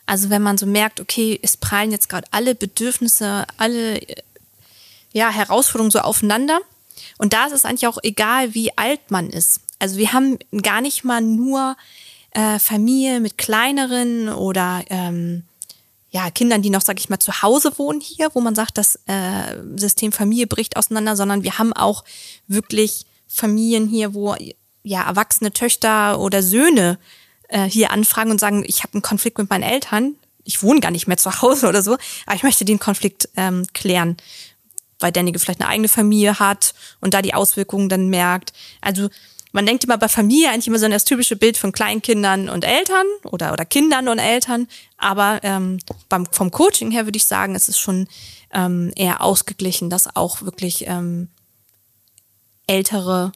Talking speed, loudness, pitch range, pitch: 175 wpm, -17 LUFS, 190-230 Hz, 210 Hz